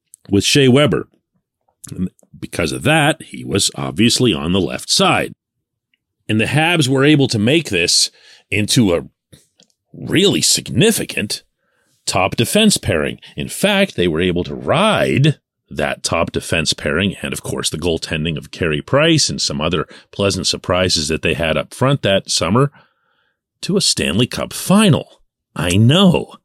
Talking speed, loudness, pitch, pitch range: 150 wpm, -16 LUFS, 125 Hz, 95-155 Hz